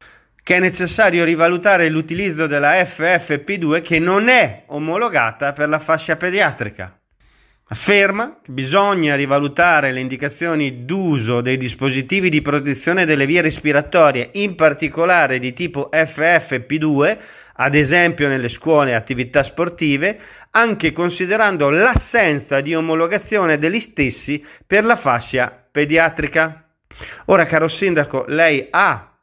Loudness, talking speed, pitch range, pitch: -16 LUFS, 115 wpm, 140-175 Hz, 160 Hz